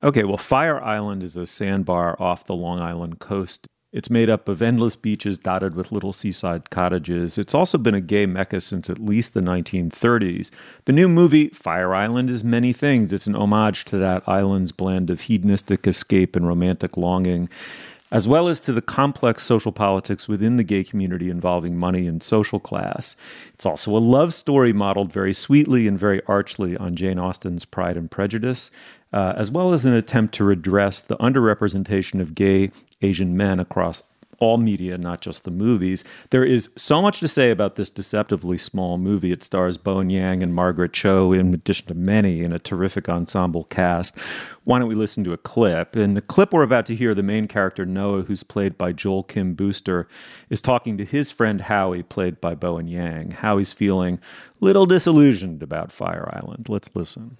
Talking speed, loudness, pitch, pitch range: 195 wpm, -21 LUFS, 100 Hz, 90-115 Hz